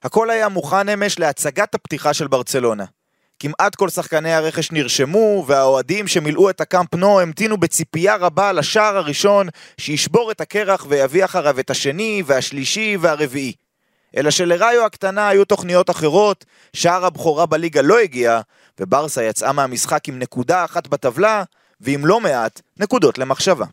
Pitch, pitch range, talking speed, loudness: 170 Hz, 145-200 Hz, 140 wpm, -17 LUFS